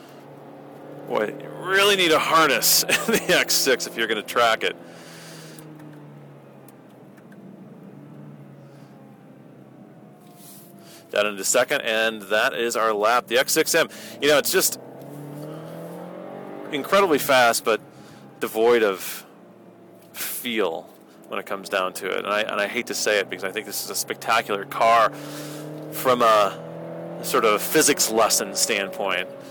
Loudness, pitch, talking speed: -21 LUFS, 115 Hz, 130 wpm